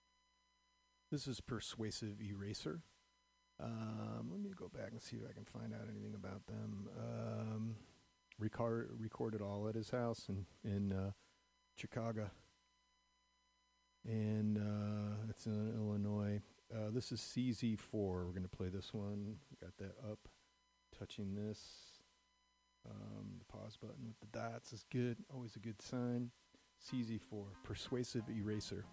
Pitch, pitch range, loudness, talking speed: 110 Hz, 100-115 Hz, -46 LUFS, 135 wpm